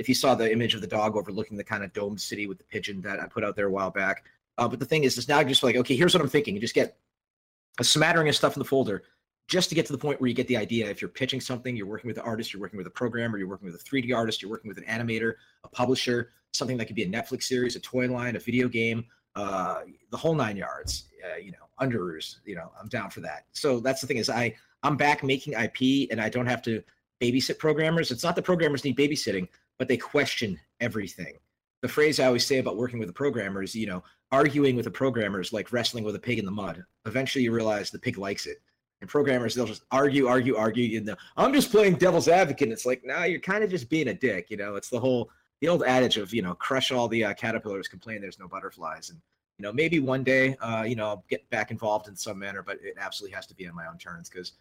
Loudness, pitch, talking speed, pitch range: -27 LUFS, 125 Hz, 270 wpm, 110-135 Hz